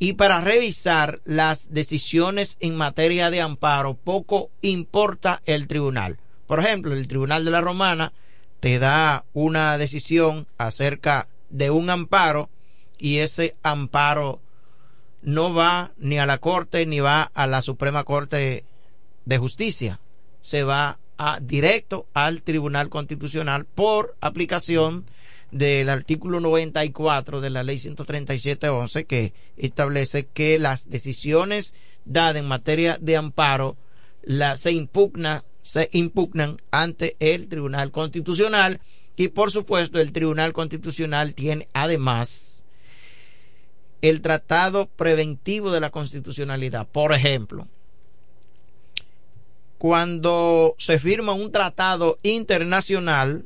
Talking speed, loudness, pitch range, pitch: 115 wpm, -22 LUFS, 140-170 Hz, 155 Hz